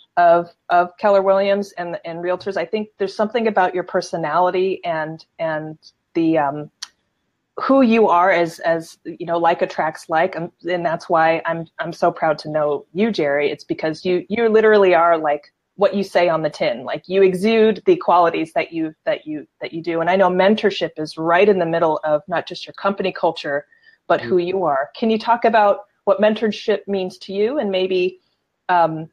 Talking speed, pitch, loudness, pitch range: 200 wpm, 180 Hz, -18 LUFS, 165-205 Hz